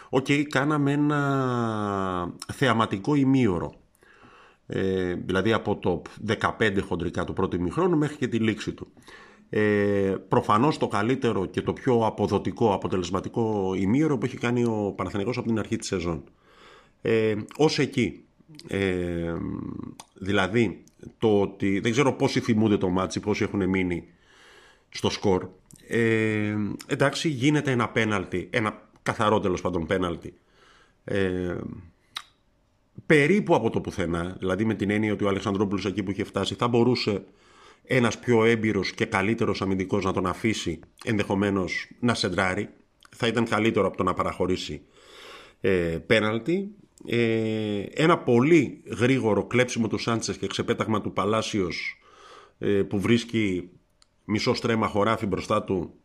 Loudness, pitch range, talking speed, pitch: -25 LUFS, 95-120 Hz, 135 wpm, 105 Hz